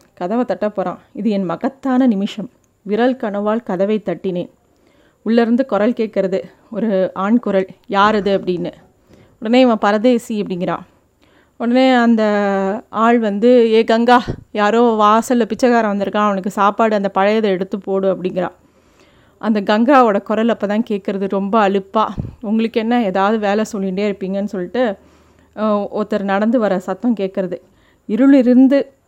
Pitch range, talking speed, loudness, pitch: 195-230 Hz, 125 wpm, -16 LUFS, 210 Hz